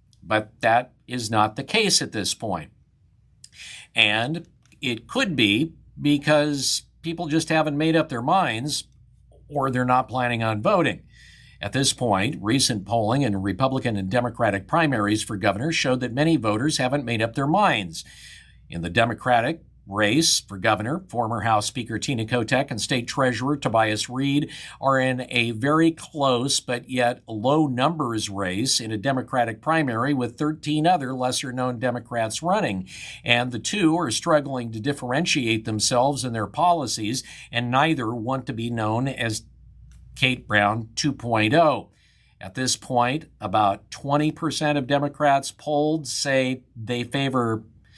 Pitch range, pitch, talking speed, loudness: 115-145 Hz, 125 Hz, 145 wpm, -23 LUFS